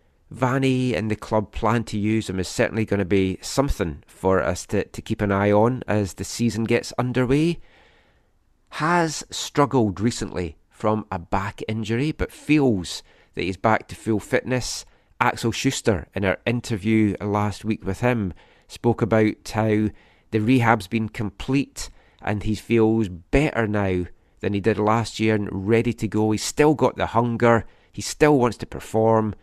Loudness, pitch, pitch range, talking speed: -23 LUFS, 110 Hz, 100-120 Hz, 165 wpm